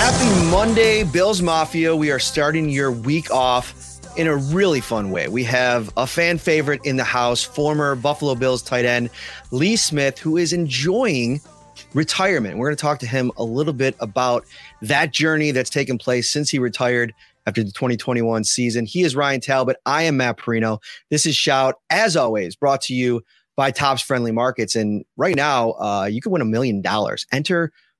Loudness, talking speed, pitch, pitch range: -19 LUFS, 185 wpm, 135 Hz, 120-150 Hz